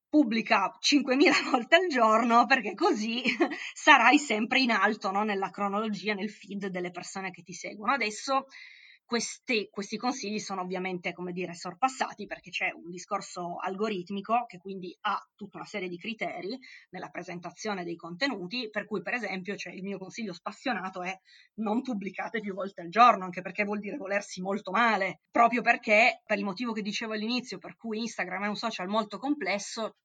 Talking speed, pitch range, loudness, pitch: 175 wpm, 190-235 Hz, -28 LUFS, 205 Hz